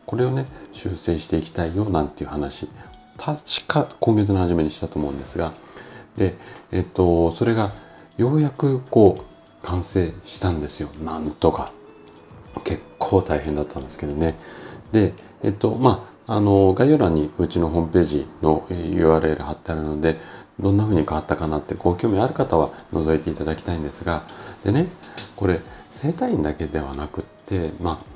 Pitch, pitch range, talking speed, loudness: 85 Hz, 75-100 Hz, 330 characters per minute, -22 LUFS